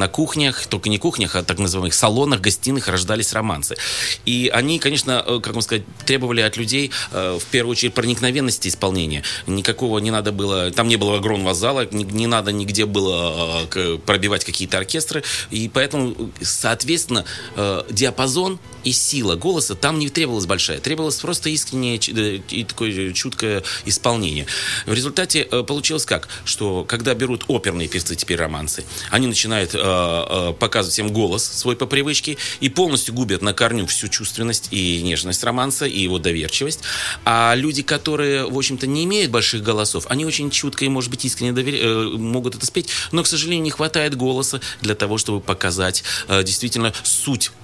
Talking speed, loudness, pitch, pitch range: 155 wpm, -19 LUFS, 115 Hz, 100-135 Hz